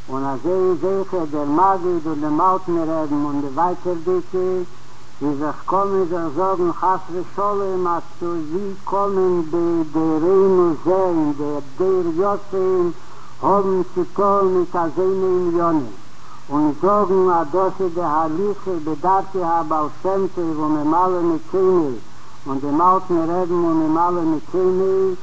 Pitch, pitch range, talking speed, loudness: 180 Hz, 160-190 Hz, 145 wpm, -19 LUFS